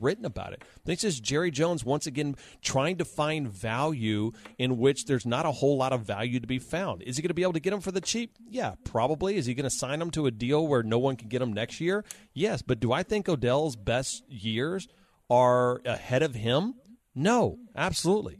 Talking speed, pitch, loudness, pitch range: 230 wpm, 145 Hz, -28 LUFS, 125-180 Hz